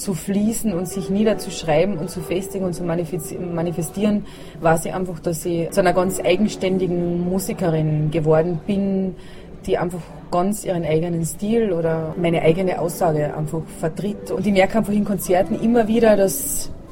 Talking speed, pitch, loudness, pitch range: 155 wpm, 180 Hz, -21 LUFS, 165-195 Hz